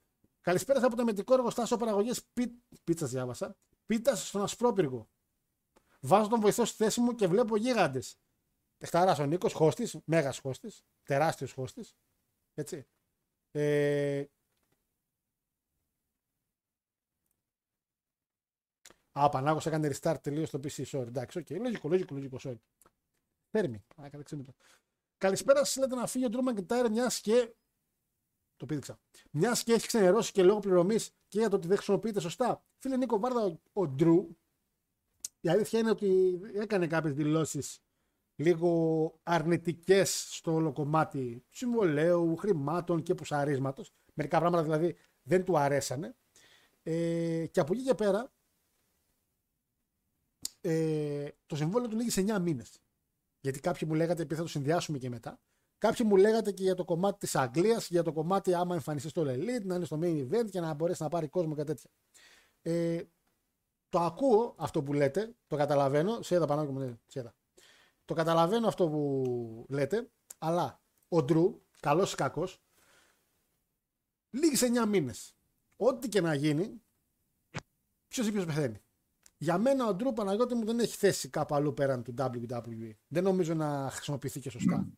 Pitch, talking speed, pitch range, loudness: 170 Hz, 150 wpm, 145-205 Hz, -31 LUFS